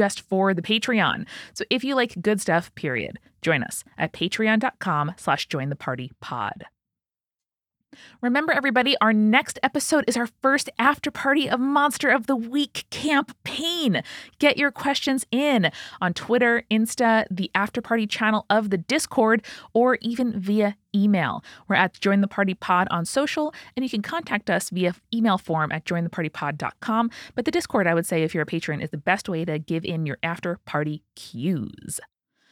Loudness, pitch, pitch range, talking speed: -23 LUFS, 215 Hz, 175-260 Hz, 170 wpm